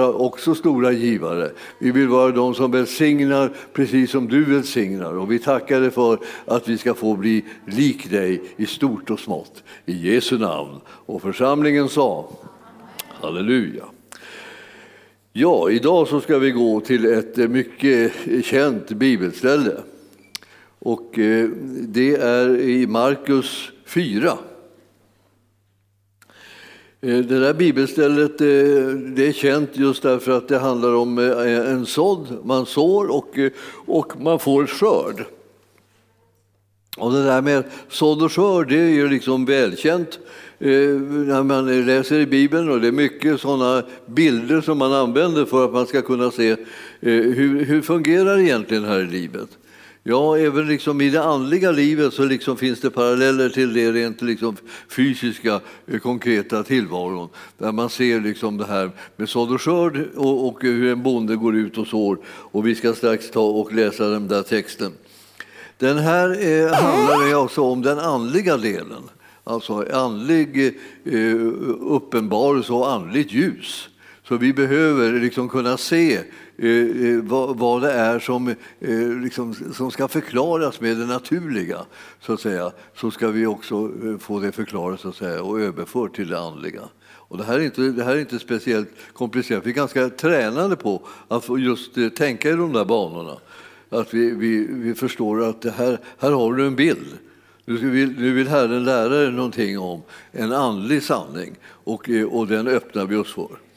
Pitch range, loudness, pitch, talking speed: 115-140 Hz, -19 LUFS, 125 Hz, 155 wpm